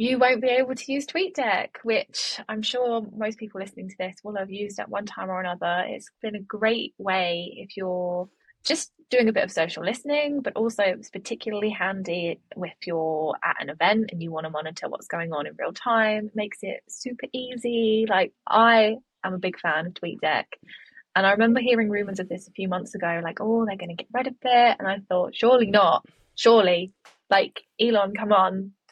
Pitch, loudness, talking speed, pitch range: 210 Hz, -24 LUFS, 210 wpm, 185-230 Hz